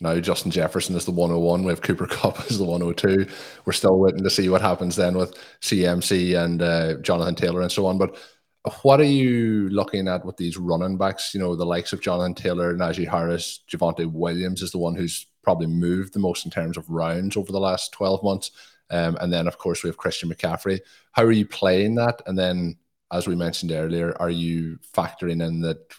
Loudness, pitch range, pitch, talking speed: -23 LUFS, 85-95 Hz, 90 Hz, 215 wpm